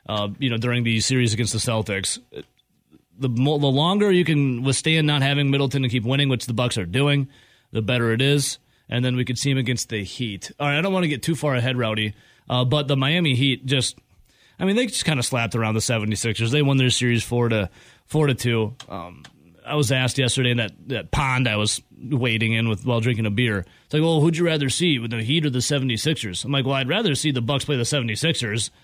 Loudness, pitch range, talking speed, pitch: -22 LUFS, 115-145 Hz, 245 wpm, 125 Hz